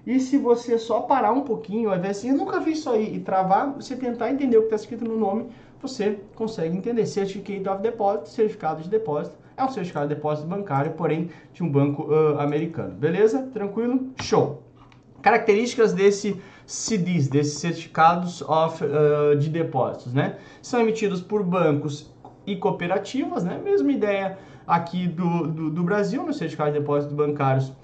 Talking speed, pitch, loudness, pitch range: 165 wpm, 195 Hz, -23 LUFS, 155-220 Hz